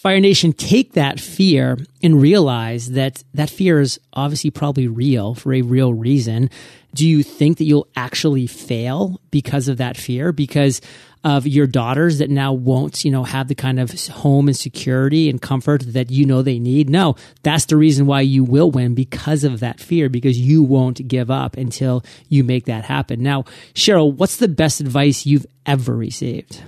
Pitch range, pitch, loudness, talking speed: 130-150 Hz, 140 Hz, -17 LUFS, 185 wpm